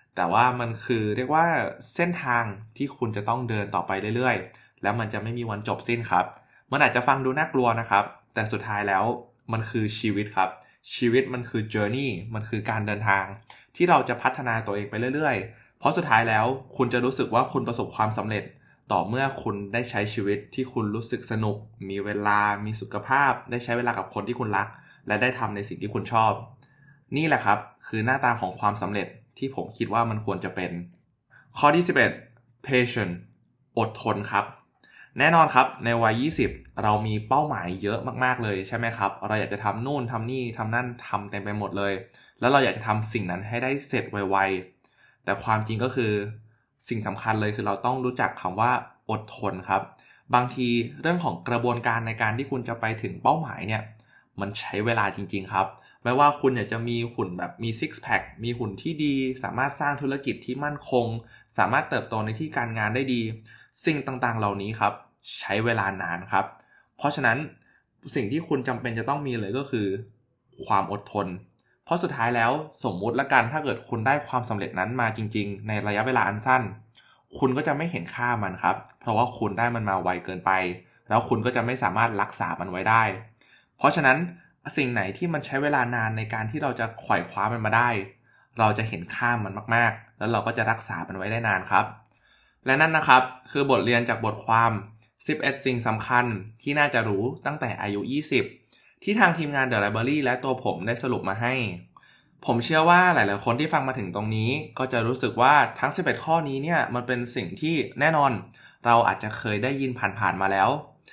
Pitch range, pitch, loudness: 105-130 Hz, 115 Hz, -25 LUFS